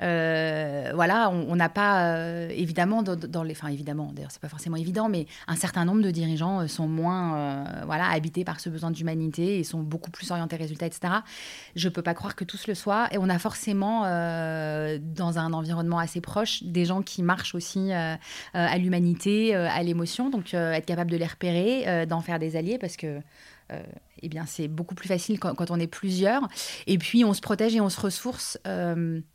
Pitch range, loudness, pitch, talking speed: 165-190 Hz, -27 LUFS, 175 Hz, 215 wpm